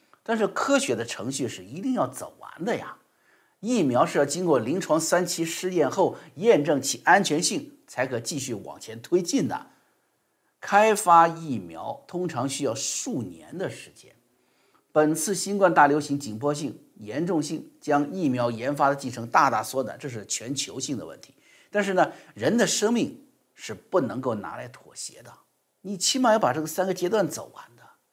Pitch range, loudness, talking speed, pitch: 145-210 Hz, -25 LUFS, 255 characters per minute, 175 Hz